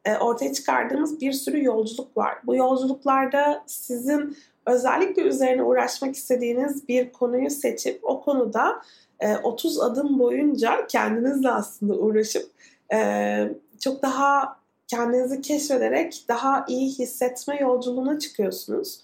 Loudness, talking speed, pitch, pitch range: -24 LUFS, 105 wpm, 265 Hz, 245-285 Hz